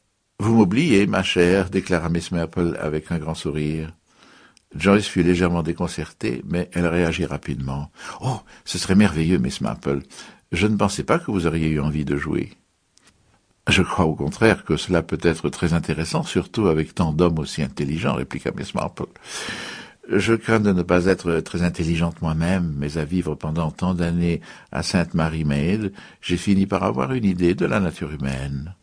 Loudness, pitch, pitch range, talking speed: -22 LUFS, 85 Hz, 80-95 Hz, 175 wpm